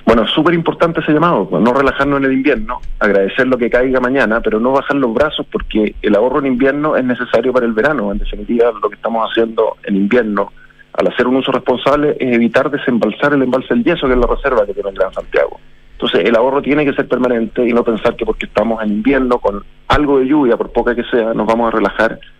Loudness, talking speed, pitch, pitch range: -14 LUFS, 230 wpm, 125 Hz, 115-140 Hz